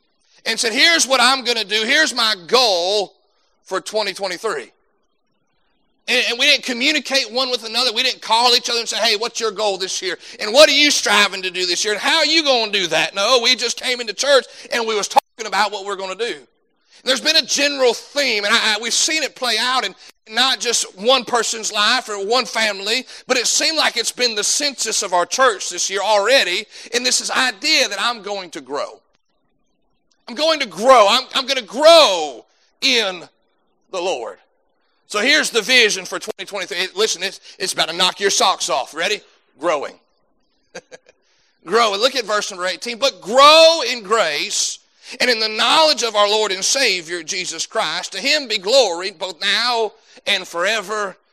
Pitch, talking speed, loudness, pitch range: 230 Hz, 200 wpm, -16 LUFS, 205-260 Hz